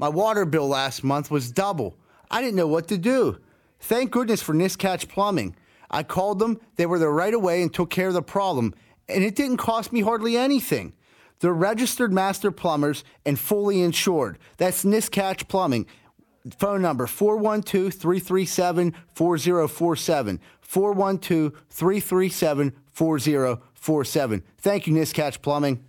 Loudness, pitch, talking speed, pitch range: -23 LUFS, 180 Hz, 140 wpm, 155-200 Hz